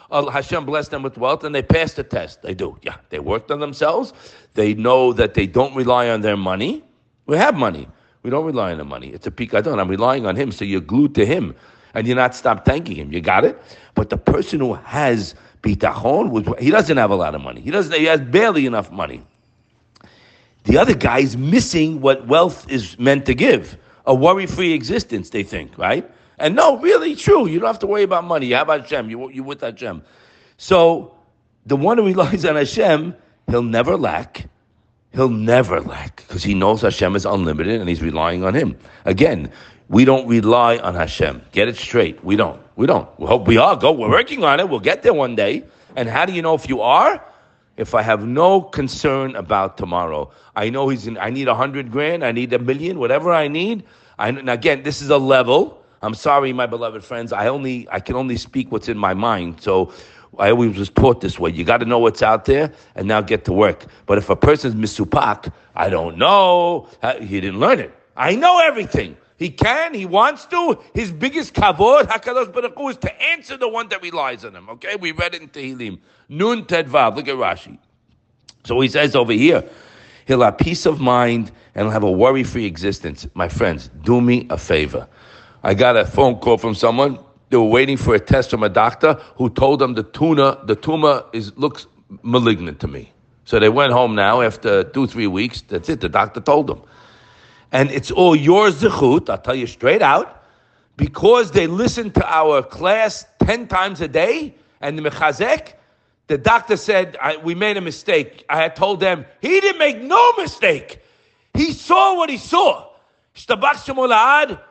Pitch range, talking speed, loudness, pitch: 115-180 Hz, 205 wpm, -17 LUFS, 135 Hz